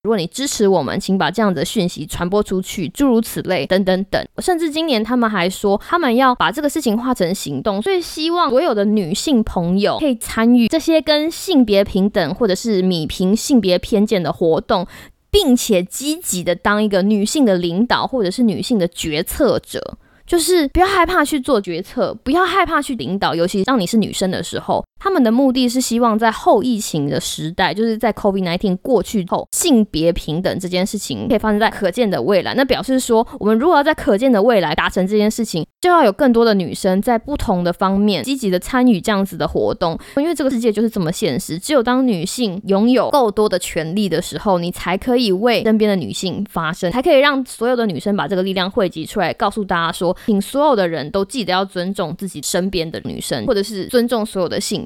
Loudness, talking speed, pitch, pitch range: -17 LUFS, 335 characters per minute, 210 Hz, 185-250 Hz